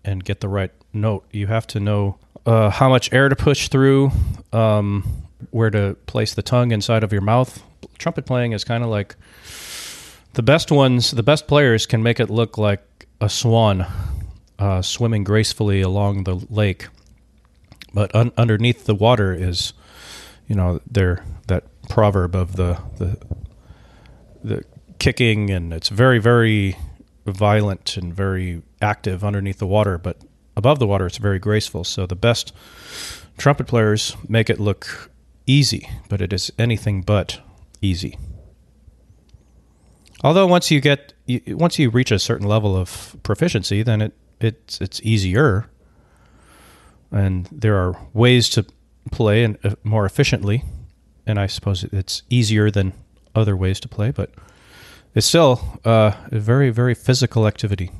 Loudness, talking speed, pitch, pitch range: -19 LUFS, 150 wpm, 105 Hz, 95-115 Hz